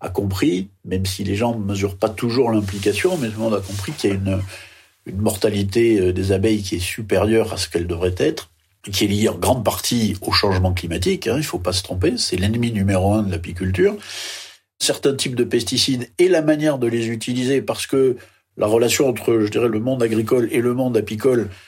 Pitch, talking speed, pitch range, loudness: 105 Hz, 220 wpm, 95-120 Hz, -20 LUFS